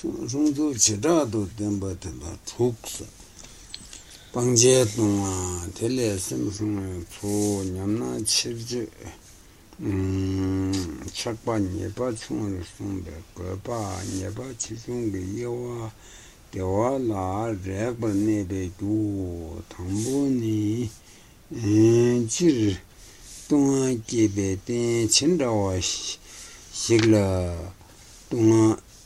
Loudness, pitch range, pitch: -25 LUFS, 95-115 Hz, 105 Hz